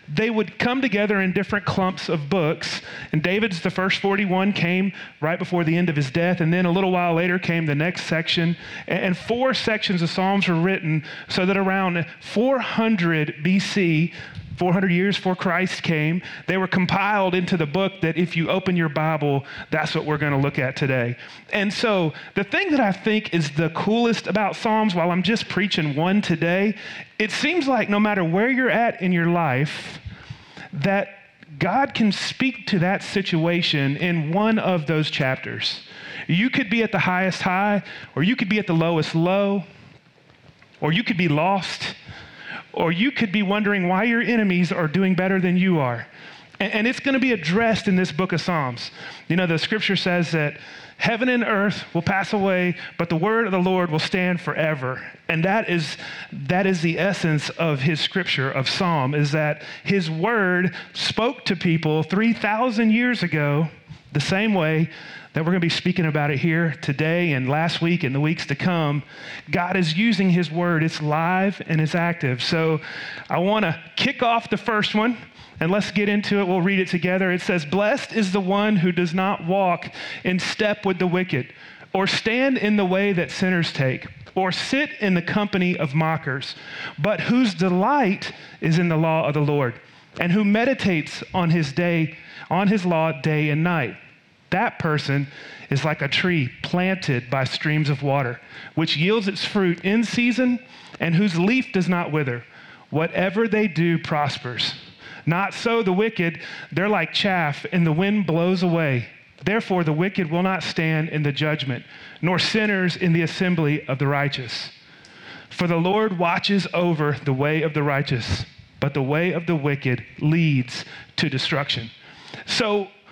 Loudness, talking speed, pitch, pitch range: -22 LUFS, 185 wpm, 175 Hz, 155-200 Hz